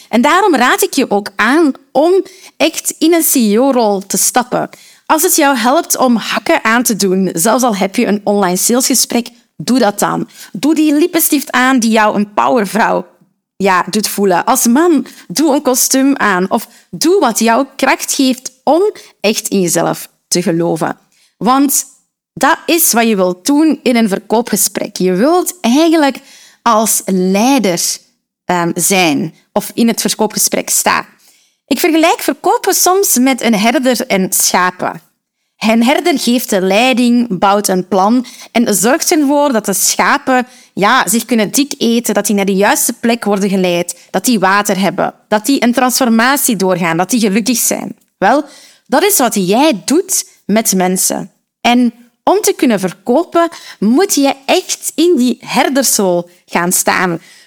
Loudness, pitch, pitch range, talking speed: -12 LUFS, 235 Hz, 200-280 Hz, 160 wpm